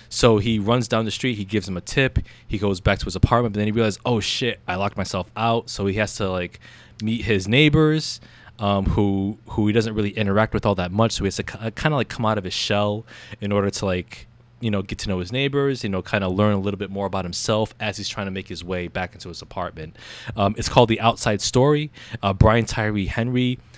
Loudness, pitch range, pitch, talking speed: -22 LUFS, 100-115 Hz, 105 Hz, 255 wpm